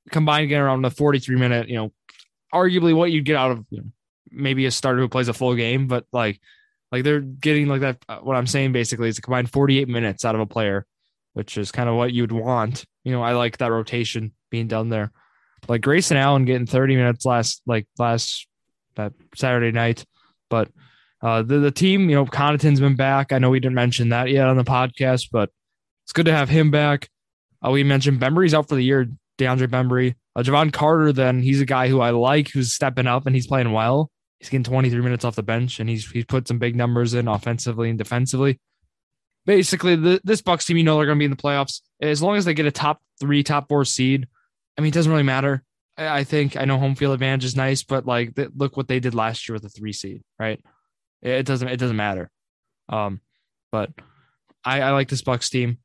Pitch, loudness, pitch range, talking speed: 130 Hz, -20 LUFS, 120-140 Hz, 230 wpm